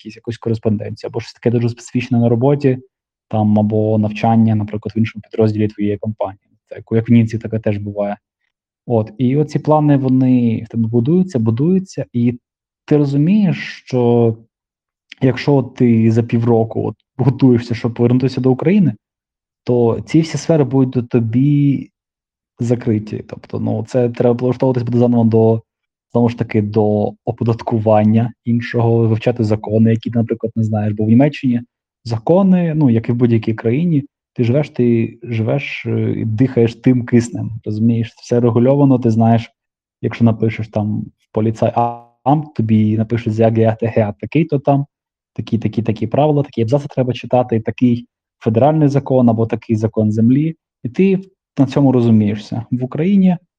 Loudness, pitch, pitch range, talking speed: -16 LUFS, 120 Hz, 110-130 Hz, 150 wpm